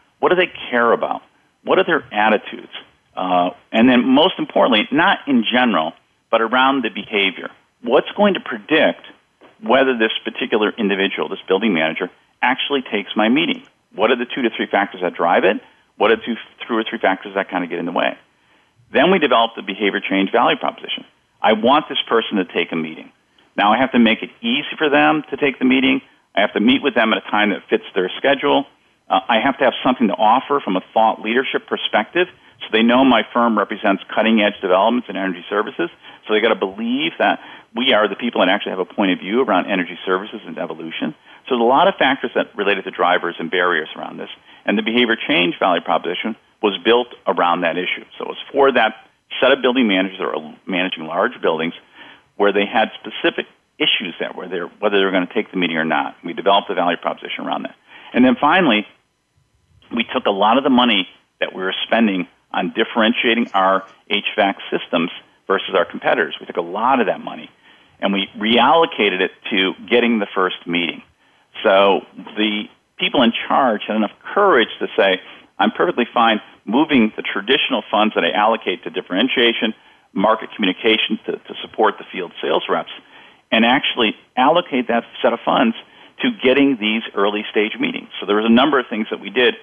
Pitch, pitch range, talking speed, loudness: 110 Hz, 95-130 Hz, 205 wpm, -17 LUFS